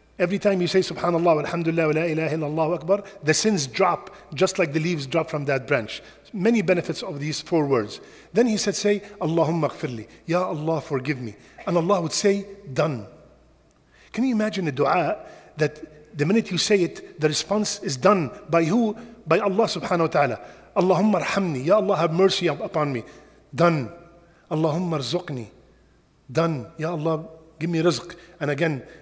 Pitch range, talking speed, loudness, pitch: 155-190 Hz, 180 wpm, -23 LUFS, 165 Hz